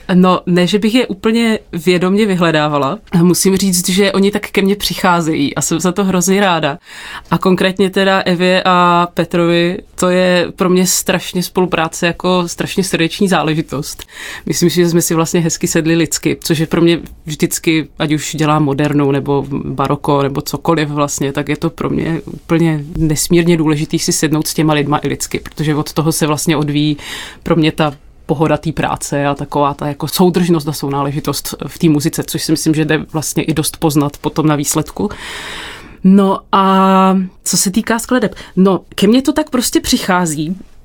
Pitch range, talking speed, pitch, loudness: 155-185 Hz, 180 wpm, 170 Hz, -14 LUFS